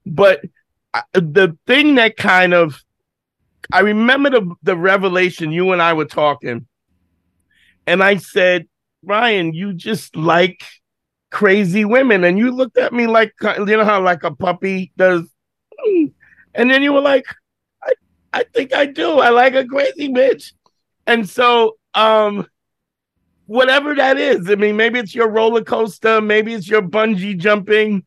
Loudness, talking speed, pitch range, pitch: -14 LUFS, 150 wpm, 180-245 Hz, 210 Hz